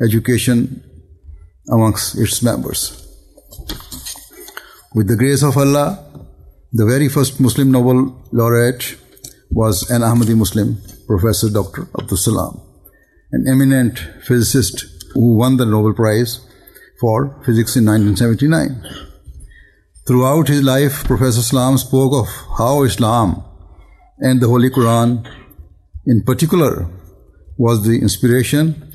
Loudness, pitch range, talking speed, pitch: -15 LUFS, 105-130 Hz, 110 wpm, 120 Hz